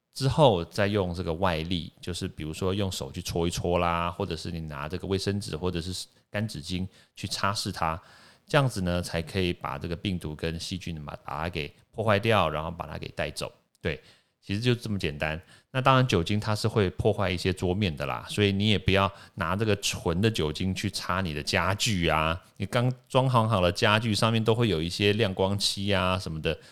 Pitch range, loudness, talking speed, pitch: 85-105 Hz, -27 LUFS, 305 characters per minute, 95 Hz